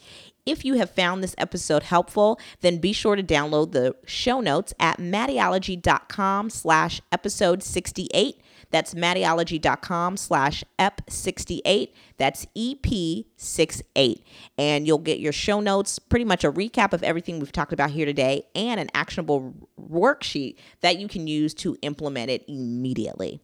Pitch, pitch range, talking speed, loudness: 175 Hz, 150-195 Hz, 140 wpm, -24 LUFS